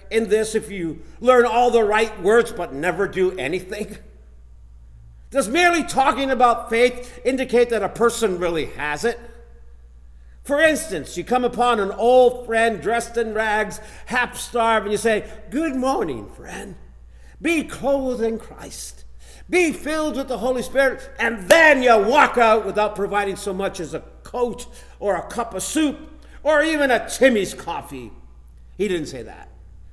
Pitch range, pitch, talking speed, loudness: 185-250 Hz, 225 Hz, 160 wpm, -20 LUFS